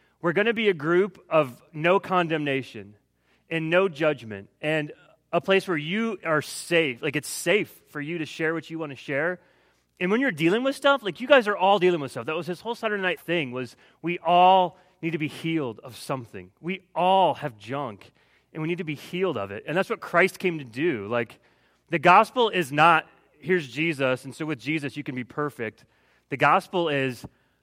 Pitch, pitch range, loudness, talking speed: 165 Hz, 140-185 Hz, -25 LUFS, 215 wpm